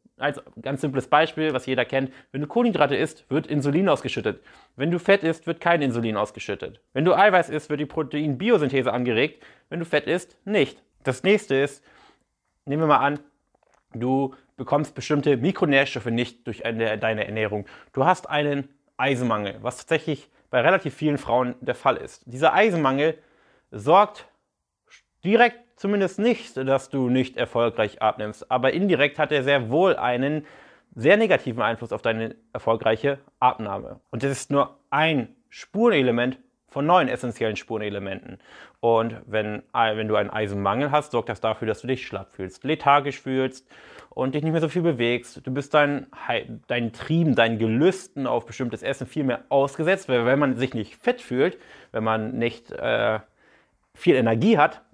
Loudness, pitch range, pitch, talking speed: -23 LUFS, 120-150 Hz, 135 Hz, 165 wpm